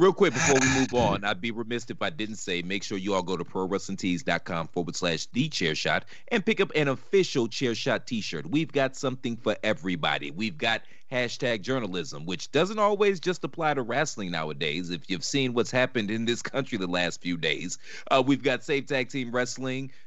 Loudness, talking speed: -27 LUFS, 210 wpm